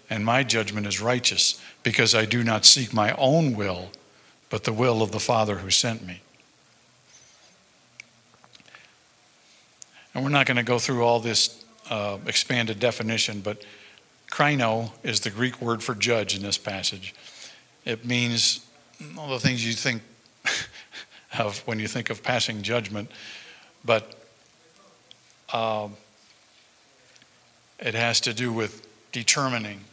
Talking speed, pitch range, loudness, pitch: 135 wpm, 105-120 Hz, -23 LUFS, 115 Hz